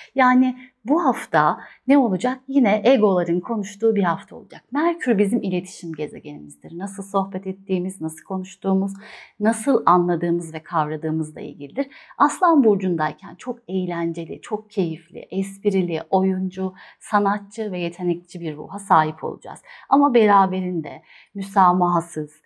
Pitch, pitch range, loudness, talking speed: 190 Hz, 175-230 Hz, -21 LUFS, 115 wpm